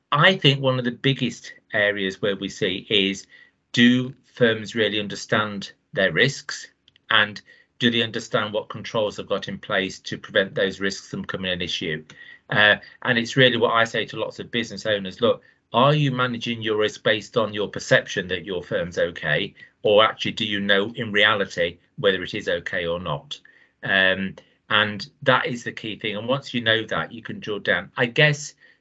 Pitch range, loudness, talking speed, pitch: 100-125 Hz, -22 LUFS, 190 wpm, 110 Hz